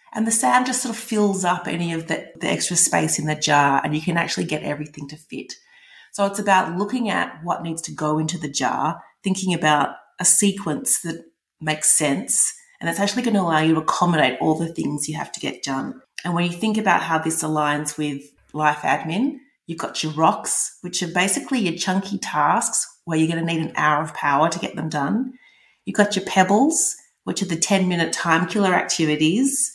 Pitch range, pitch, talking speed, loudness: 155-200 Hz, 170 Hz, 215 wpm, -21 LUFS